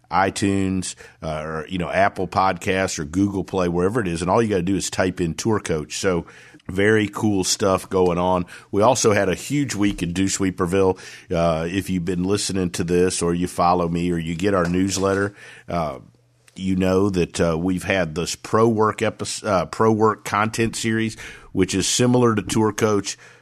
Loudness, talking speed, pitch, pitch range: -21 LUFS, 195 wpm, 95 Hz, 90-105 Hz